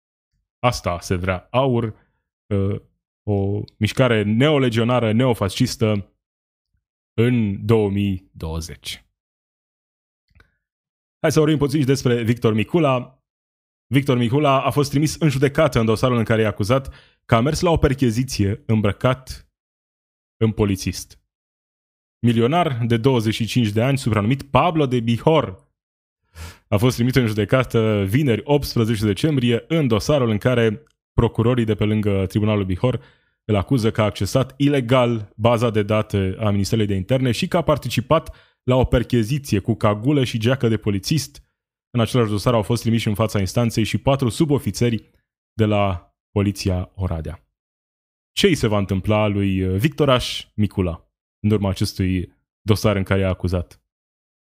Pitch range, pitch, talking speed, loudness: 100-125 Hz, 110 Hz, 140 wpm, -20 LUFS